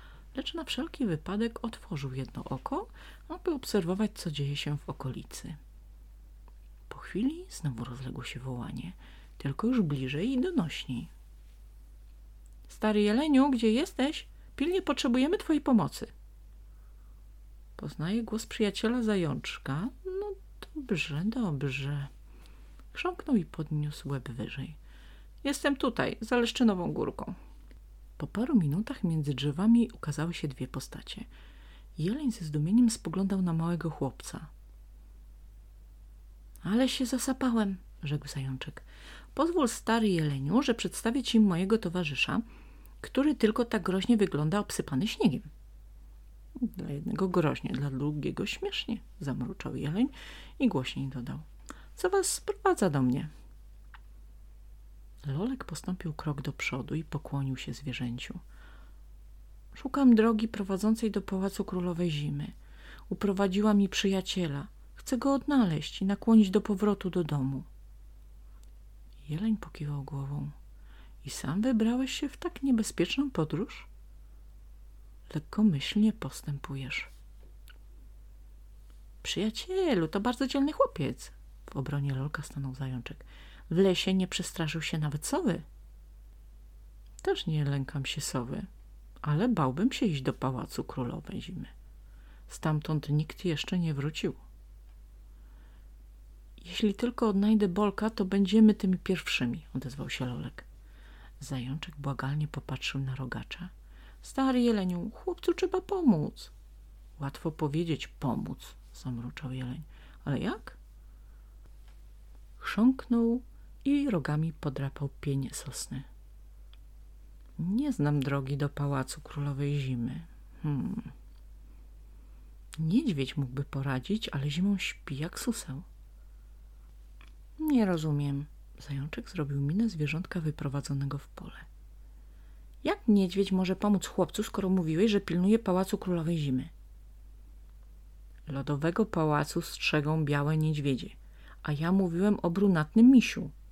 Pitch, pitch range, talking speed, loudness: 175 Hz, 140-225 Hz, 110 wpm, -31 LUFS